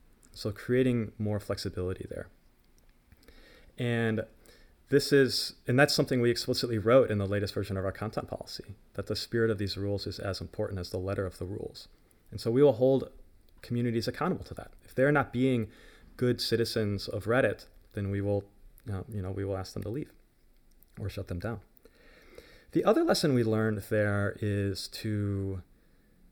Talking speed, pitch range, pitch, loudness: 180 wpm, 100-120 Hz, 105 Hz, -30 LUFS